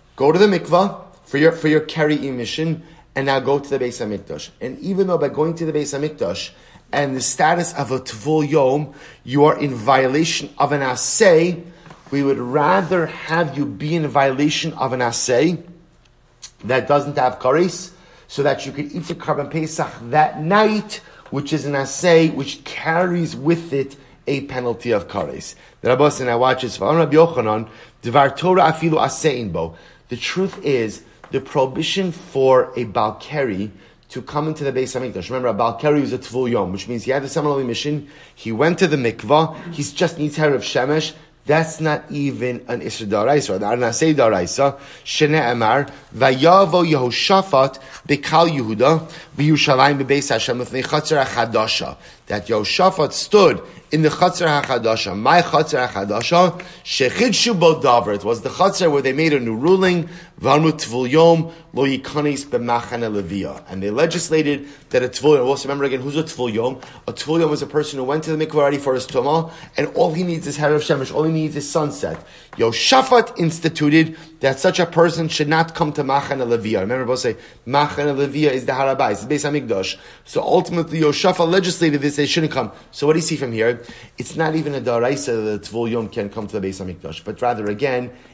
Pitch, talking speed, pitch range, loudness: 145 Hz, 170 wpm, 130-160 Hz, -18 LUFS